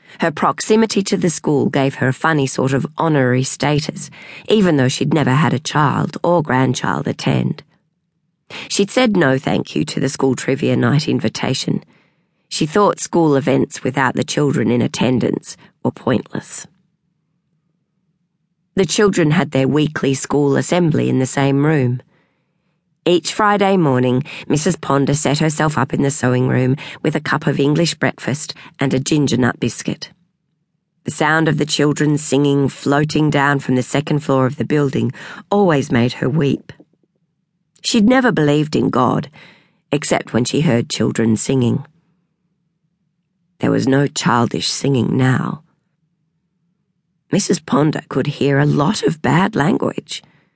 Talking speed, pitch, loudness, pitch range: 145 wpm, 155 Hz, -16 LUFS, 135-175 Hz